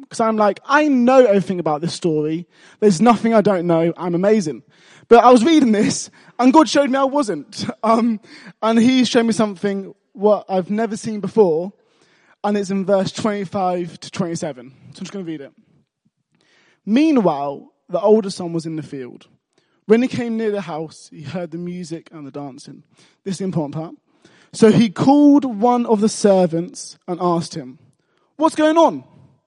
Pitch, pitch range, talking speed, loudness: 200 Hz, 165-230 Hz, 185 wpm, -17 LUFS